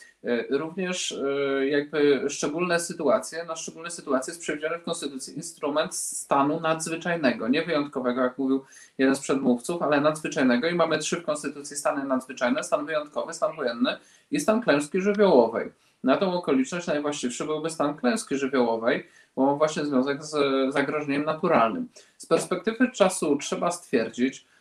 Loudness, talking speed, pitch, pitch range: -26 LUFS, 145 wpm, 150 Hz, 135-170 Hz